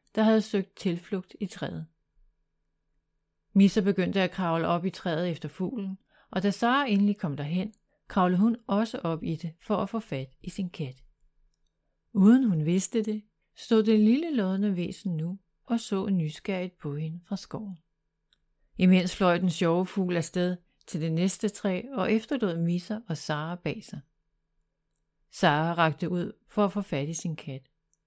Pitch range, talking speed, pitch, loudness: 165-205 Hz, 170 wpm, 185 Hz, -28 LUFS